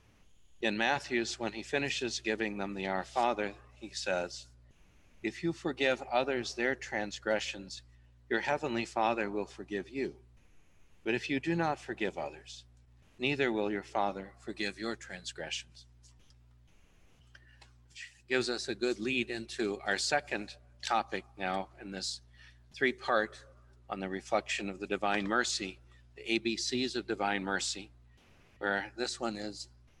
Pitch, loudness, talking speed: 100 Hz, -34 LUFS, 140 wpm